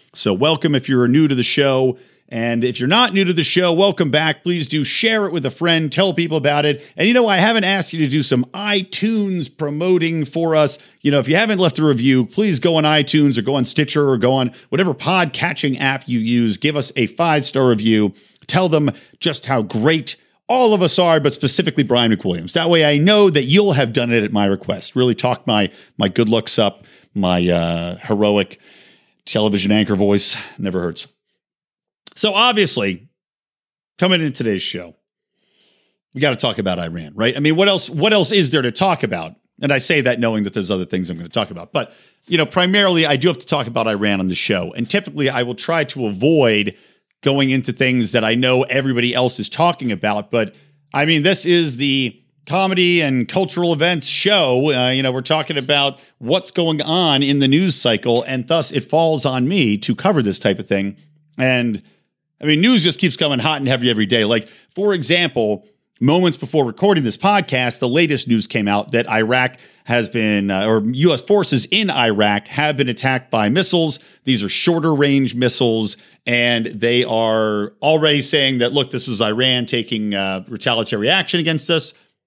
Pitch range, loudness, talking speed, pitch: 120-165 Hz, -16 LUFS, 205 wpm, 140 Hz